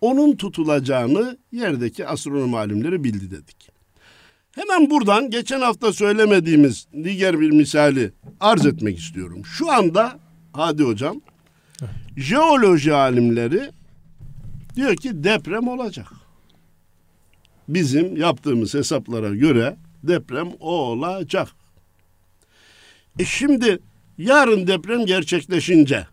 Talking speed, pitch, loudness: 90 wpm, 150 Hz, -19 LUFS